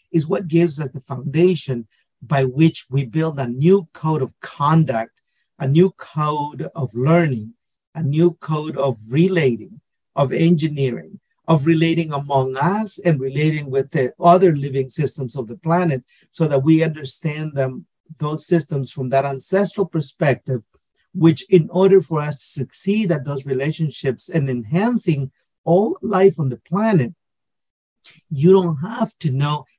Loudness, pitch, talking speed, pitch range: -19 LUFS, 155 Hz, 150 wpm, 135-170 Hz